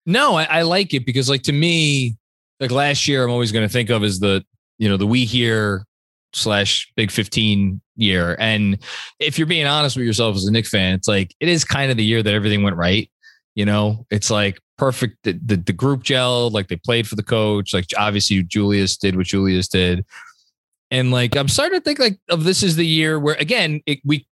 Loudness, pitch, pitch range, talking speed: -18 LUFS, 115 Hz, 100-140 Hz, 225 wpm